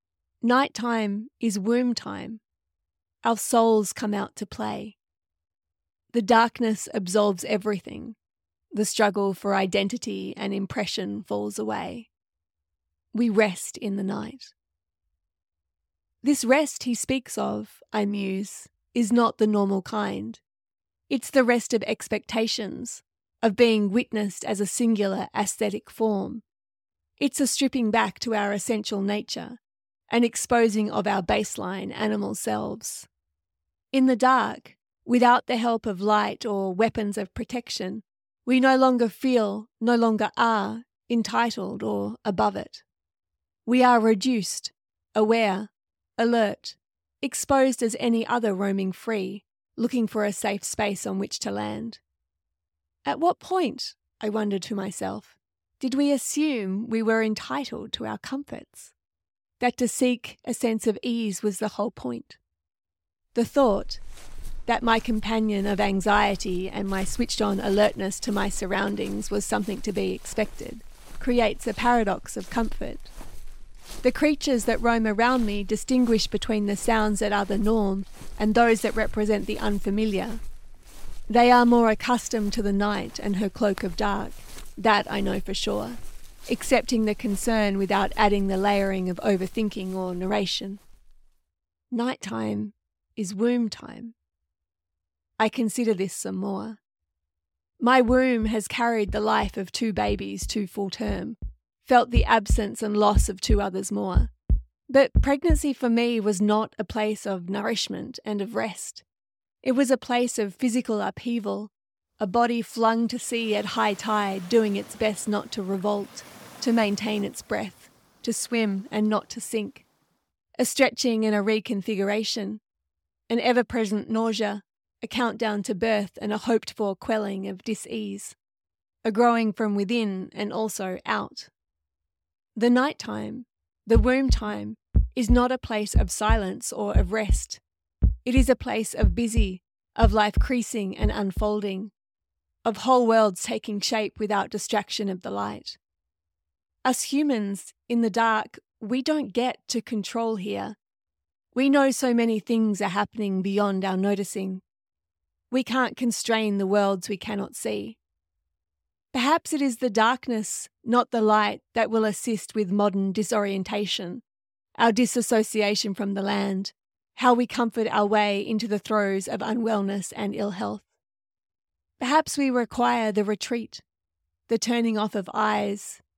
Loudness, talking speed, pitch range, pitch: -25 LUFS, 140 wpm, 195-235 Hz, 215 Hz